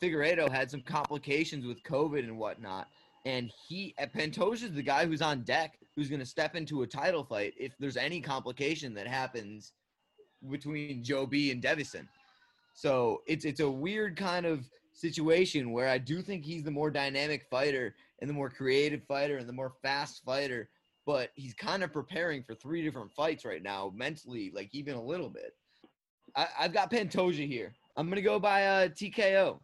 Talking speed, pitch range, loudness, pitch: 190 wpm, 130-165 Hz, -33 LUFS, 145 Hz